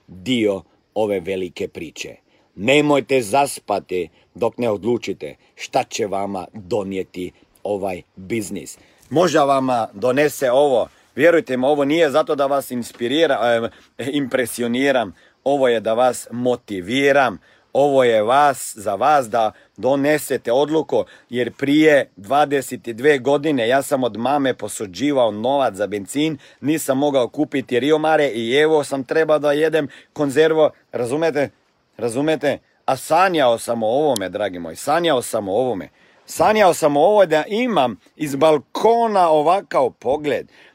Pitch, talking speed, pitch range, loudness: 140 Hz, 130 wpm, 120-155 Hz, -19 LUFS